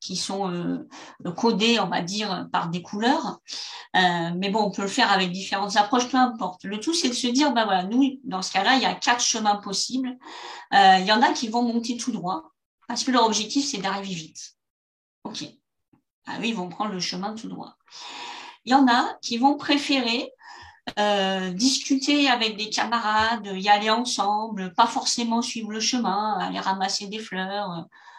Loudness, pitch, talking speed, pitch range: -23 LUFS, 220 Hz, 195 wpm, 195-250 Hz